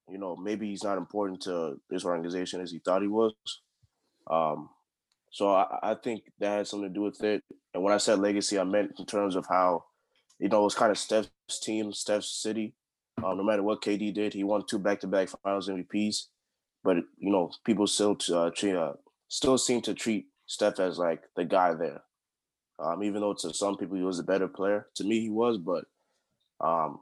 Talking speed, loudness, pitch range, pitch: 210 wpm, -30 LUFS, 95-105 Hz, 100 Hz